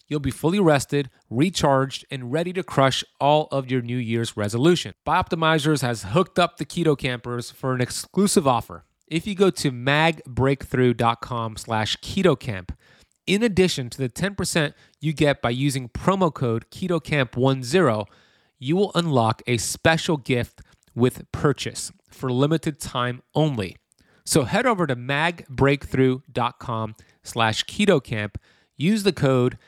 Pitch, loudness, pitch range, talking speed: 135 Hz, -23 LUFS, 120-160 Hz, 125 wpm